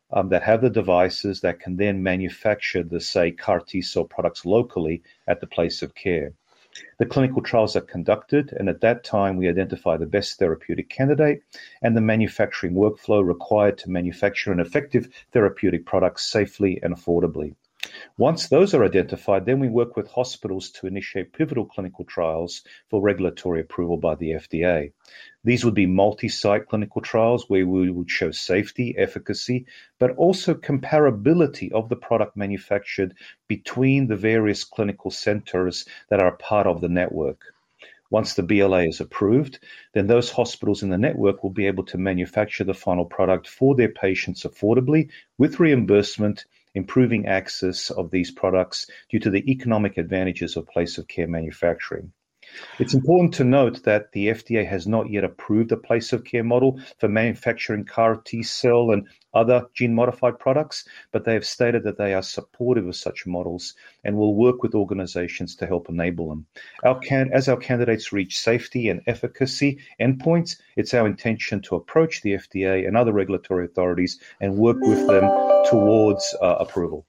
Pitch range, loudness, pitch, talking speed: 95-120 Hz, -22 LUFS, 105 Hz, 165 wpm